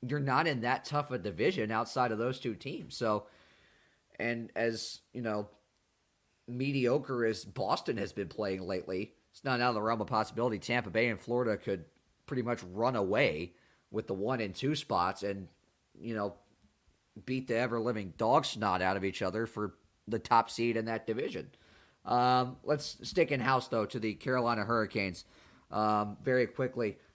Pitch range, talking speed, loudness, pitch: 105-125 Hz, 170 wpm, -33 LUFS, 115 Hz